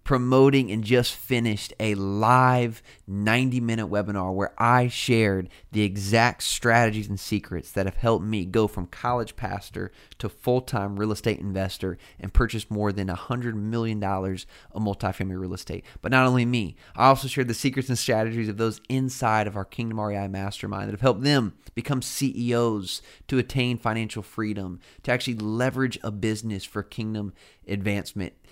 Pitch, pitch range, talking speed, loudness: 110 Hz, 100-120 Hz, 165 wpm, -25 LUFS